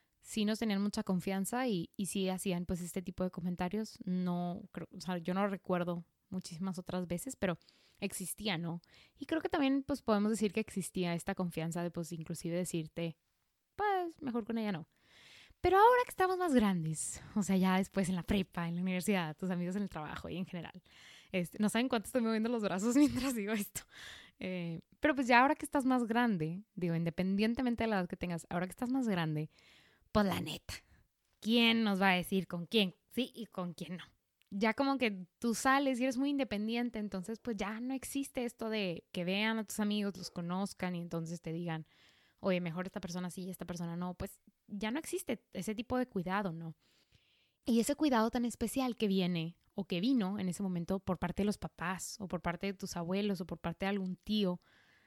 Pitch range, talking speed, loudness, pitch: 180-225 Hz, 215 wpm, -35 LUFS, 195 Hz